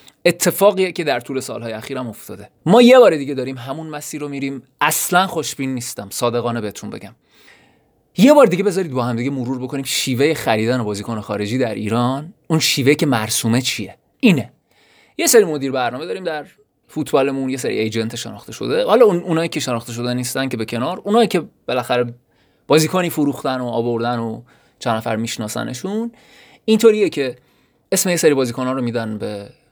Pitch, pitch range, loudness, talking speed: 130 Hz, 120-160 Hz, -18 LUFS, 170 wpm